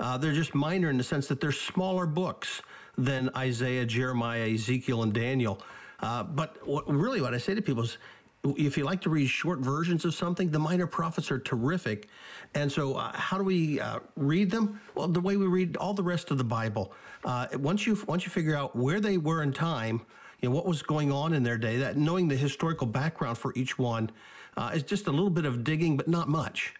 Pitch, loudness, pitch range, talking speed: 150 Hz, -30 LUFS, 130-175 Hz, 225 wpm